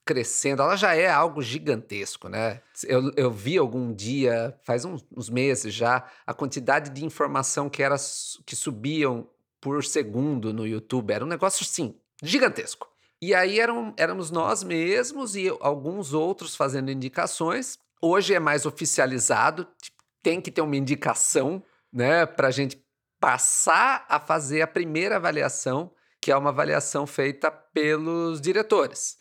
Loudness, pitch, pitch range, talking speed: -25 LUFS, 145 Hz, 130-165 Hz, 145 wpm